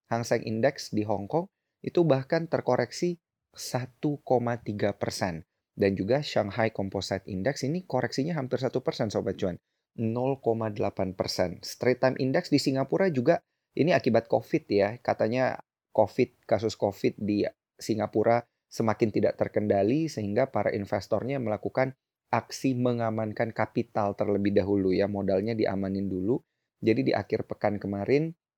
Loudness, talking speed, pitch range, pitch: -28 LUFS, 130 wpm, 100-130 Hz, 115 Hz